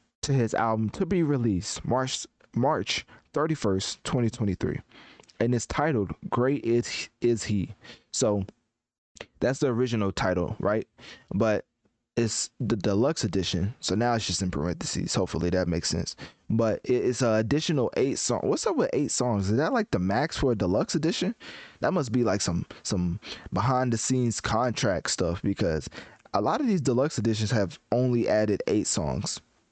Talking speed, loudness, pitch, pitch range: 170 wpm, -27 LUFS, 115 Hz, 100-125 Hz